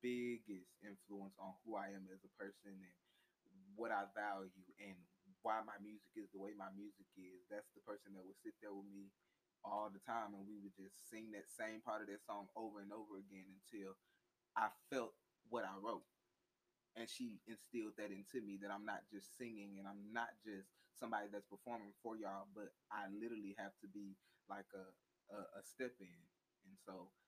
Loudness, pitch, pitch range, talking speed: -52 LUFS, 100 Hz, 95-110 Hz, 200 wpm